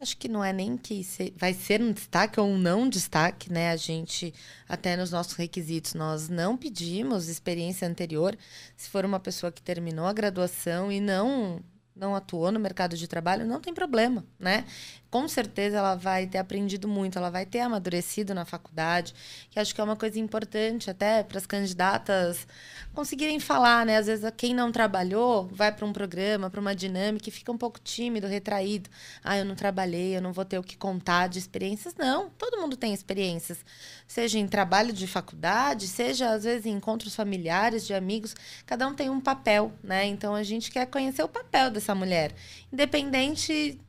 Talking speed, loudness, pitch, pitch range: 190 wpm, -28 LUFS, 200 Hz, 180-225 Hz